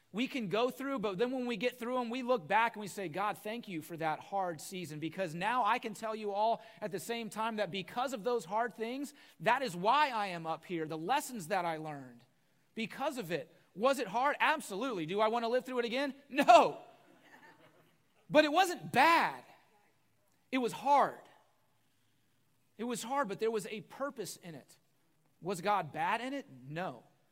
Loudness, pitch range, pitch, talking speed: -34 LUFS, 175-255 Hz, 220 Hz, 200 wpm